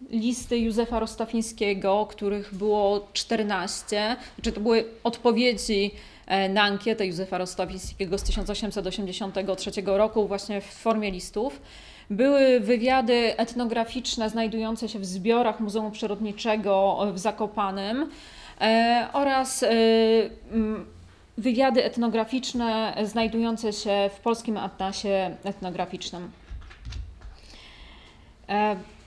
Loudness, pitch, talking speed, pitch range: -26 LUFS, 215 Hz, 85 wpm, 195-230 Hz